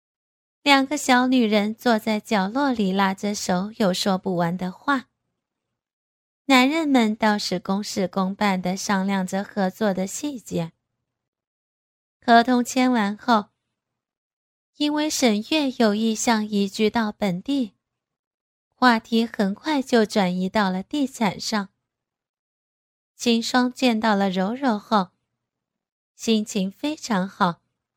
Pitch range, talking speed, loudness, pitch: 195-250 Hz, 170 characters per minute, -22 LUFS, 215 Hz